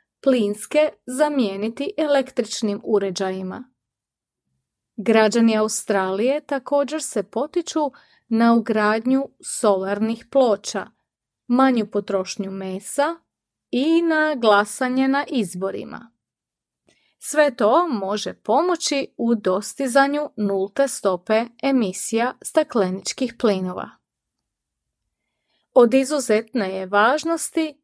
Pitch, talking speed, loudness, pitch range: 235 Hz, 80 wpm, -21 LUFS, 205-280 Hz